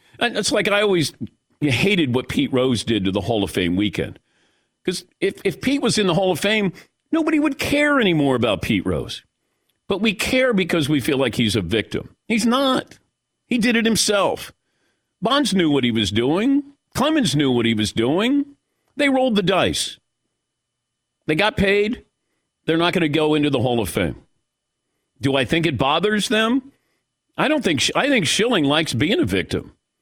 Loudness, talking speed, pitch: -19 LUFS, 190 wpm, 185 Hz